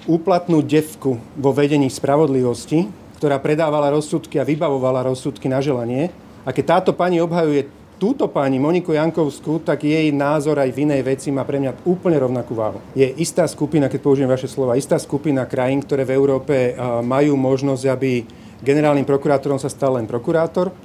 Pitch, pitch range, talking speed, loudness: 140 Hz, 130-155 Hz, 165 wpm, -19 LUFS